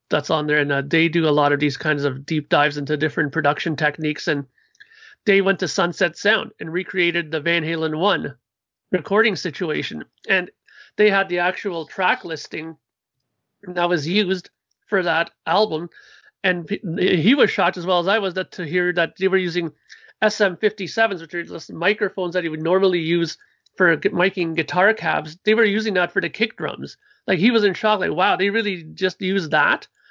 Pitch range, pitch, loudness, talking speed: 160-200 Hz, 180 Hz, -20 LUFS, 195 wpm